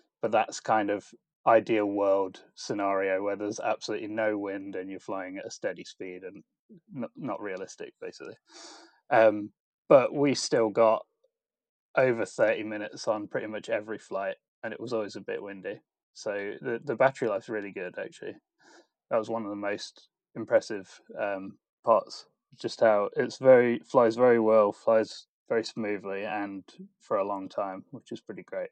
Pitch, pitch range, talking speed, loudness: 110 Hz, 100-125 Hz, 165 wpm, -28 LUFS